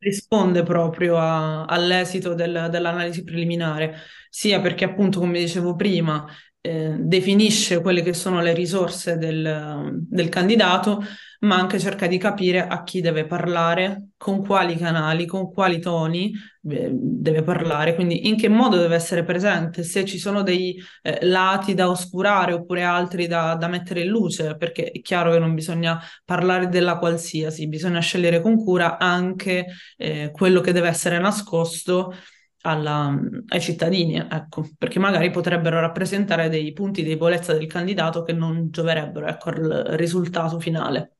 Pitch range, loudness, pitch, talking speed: 165-185 Hz, -21 LUFS, 175 Hz, 150 wpm